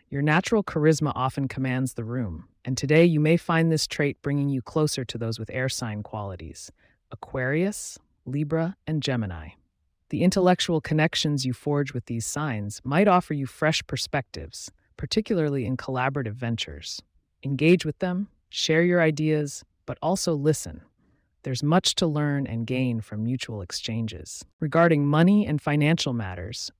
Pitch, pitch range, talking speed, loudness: 140 Hz, 120-160 Hz, 150 wpm, -25 LUFS